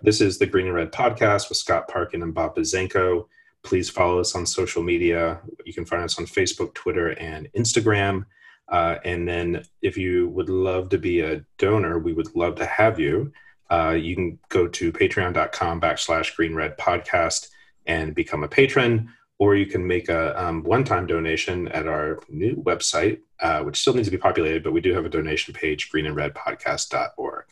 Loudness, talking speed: -23 LUFS, 180 wpm